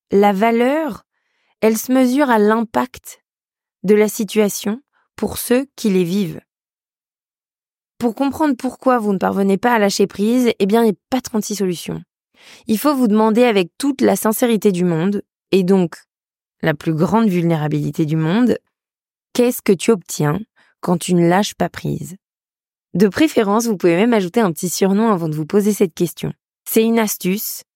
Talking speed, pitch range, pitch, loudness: 170 wpm, 185-235 Hz, 210 Hz, -17 LUFS